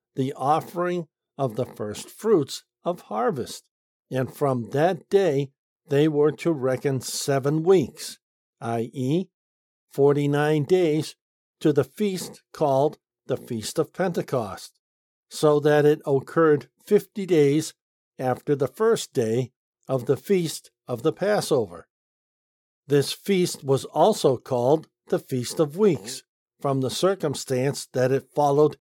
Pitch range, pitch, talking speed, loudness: 130-165 Hz, 145 Hz, 125 wpm, -24 LUFS